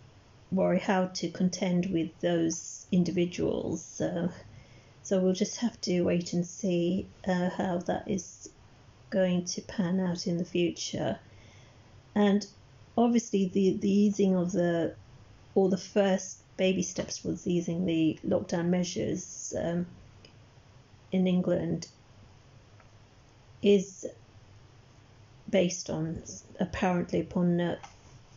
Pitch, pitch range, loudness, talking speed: 175 Hz, 120-185 Hz, -30 LUFS, 110 wpm